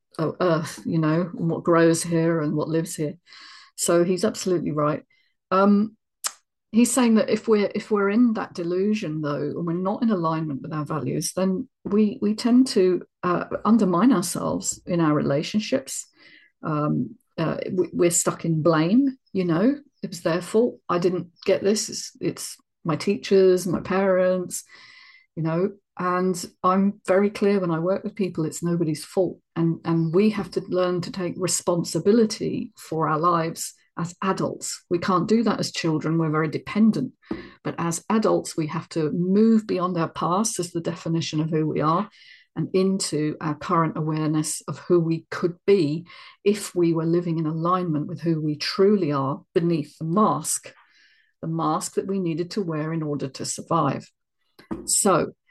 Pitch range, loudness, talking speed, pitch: 160-200 Hz, -23 LUFS, 175 wpm, 175 Hz